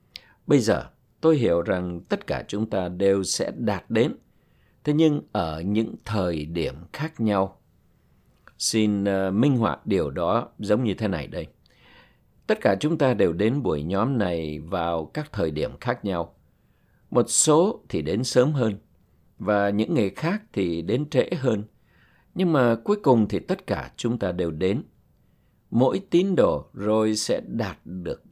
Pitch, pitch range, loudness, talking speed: 105 Hz, 90-125 Hz, -24 LUFS, 165 wpm